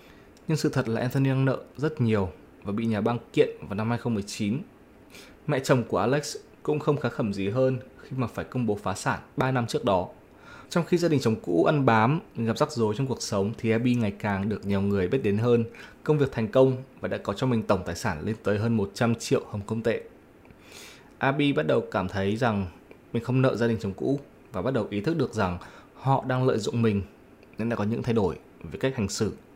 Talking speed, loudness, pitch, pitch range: 240 wpm, -27 LUFS, 115 Hz, 100-130 Hz